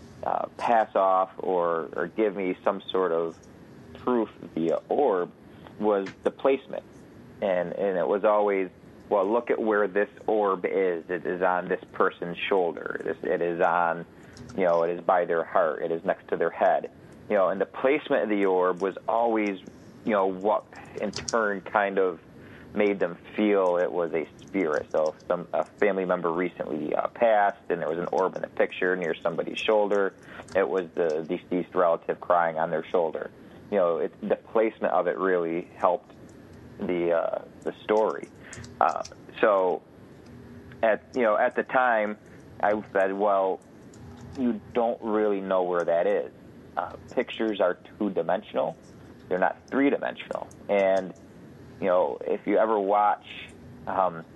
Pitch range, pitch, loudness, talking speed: 90-105 Hz, 95 Hz, -26 LUFS, 170 wpm